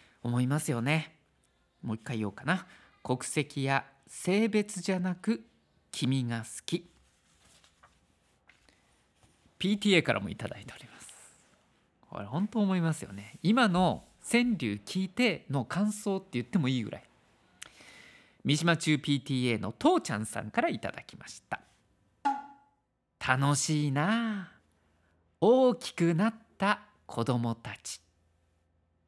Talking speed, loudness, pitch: 230 characters per minute, -30 LUFS, 140 Hz